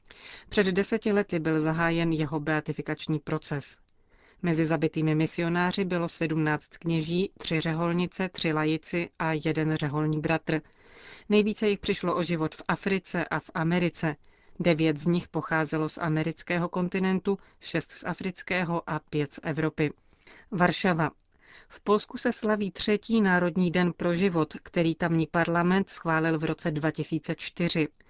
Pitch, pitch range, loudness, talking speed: 170 Hz, 155-180 Hz, -28 LUFS, 135 wpm